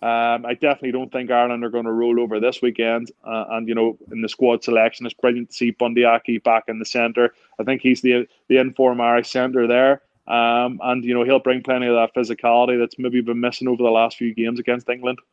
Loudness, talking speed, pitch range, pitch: -19 LUFS, 230 wpm, 115-125 Hz, 120 Hz